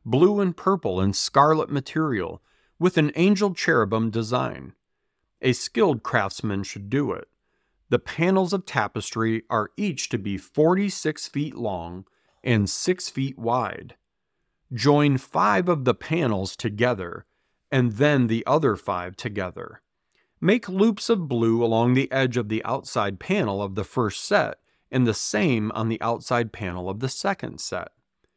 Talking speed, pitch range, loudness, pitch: 150 wpm, 110-155 Hz, -24 LUFS, 125 Hz